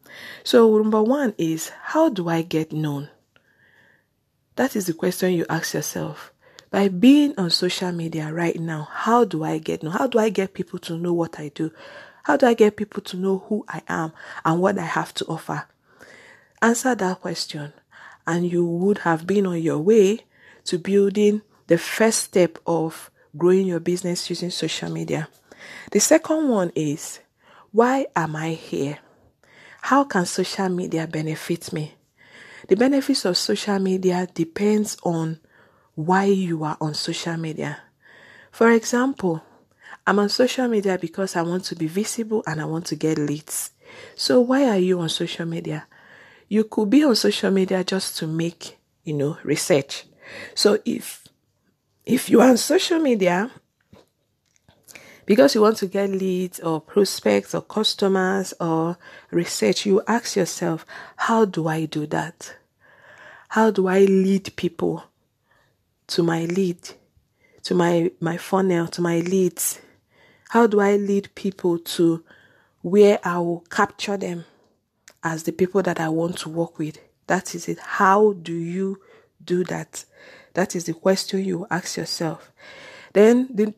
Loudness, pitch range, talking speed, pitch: -21 LUFS, 165-210 Hz, 160 wpm, 185 Hz